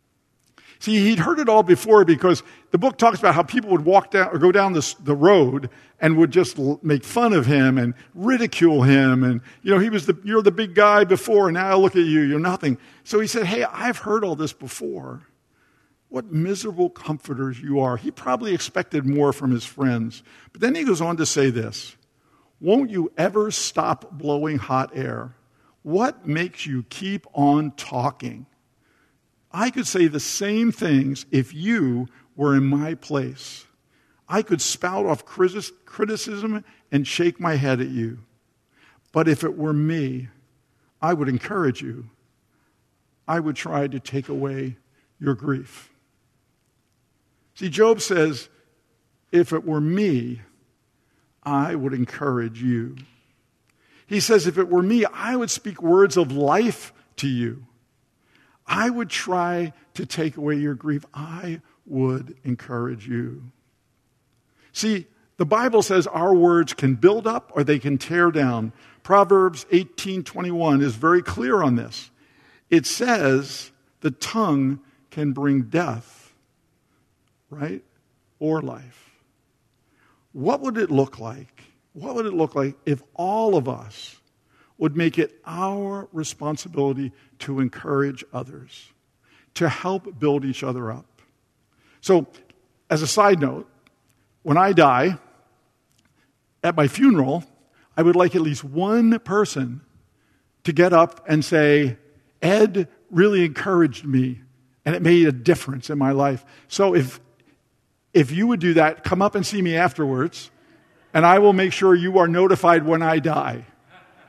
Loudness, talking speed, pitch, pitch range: -21 LUFS, 150 wpm, 150 Hz, 130-180 Hz